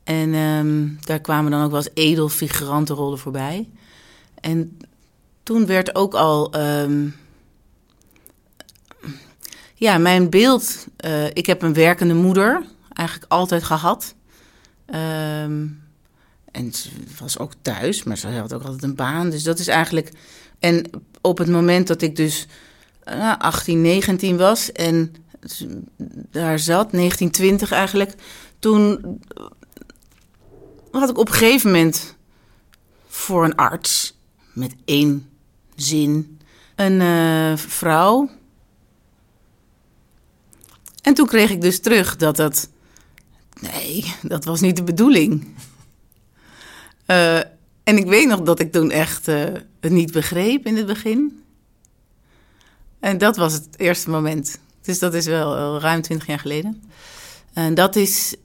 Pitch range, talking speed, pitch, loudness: 150-195 Hz, 130 wpm, 165 Hz, -18 LUFS